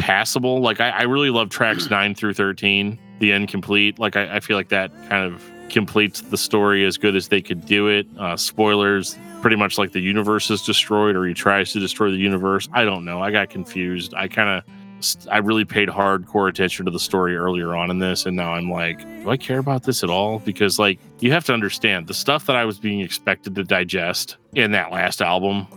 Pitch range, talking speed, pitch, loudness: 95-110 Hz, 225 wpm, 100 Hz, -19 LUFS